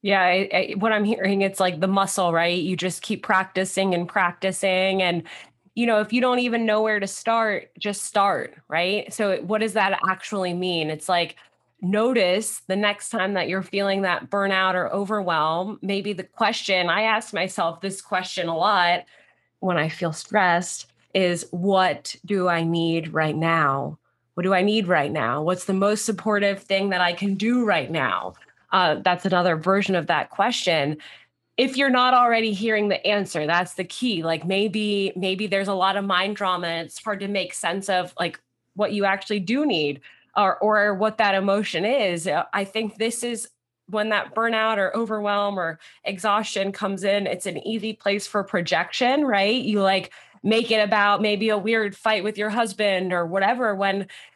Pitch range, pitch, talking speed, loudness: 180-210 Hz, 195 Hz, 185 wpm, -22 LUFS